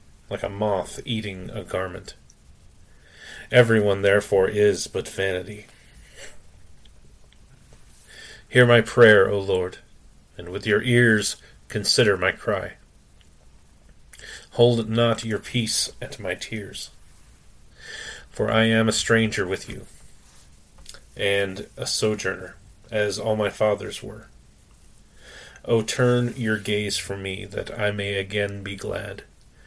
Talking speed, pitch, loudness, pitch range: 115 wpm, 105 Hz, -22 LUFS, 100-110 Hz